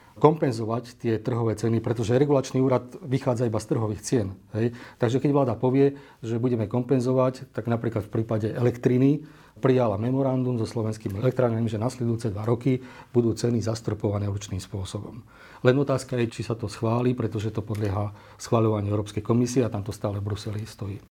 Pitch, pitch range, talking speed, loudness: 115 Hz, 110-130 Hz, 165 wpm, -26 LUFS